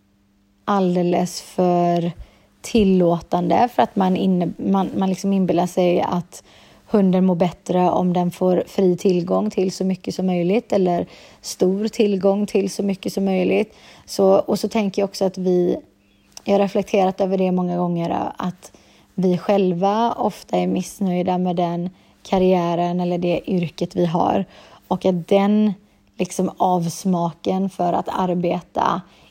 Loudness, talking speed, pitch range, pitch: -20 LUFS, 145 wpm, 175-195 Hz, 185 Hz